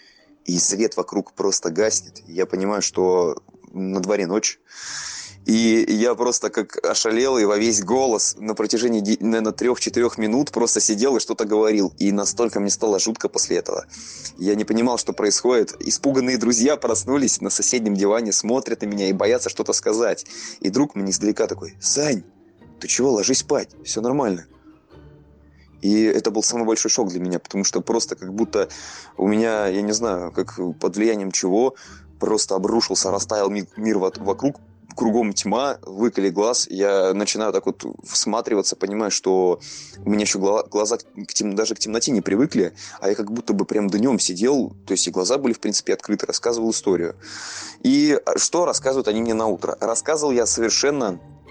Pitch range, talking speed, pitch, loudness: 100-115 Hz, 170 wpm, 110 Hz, -21 LUFS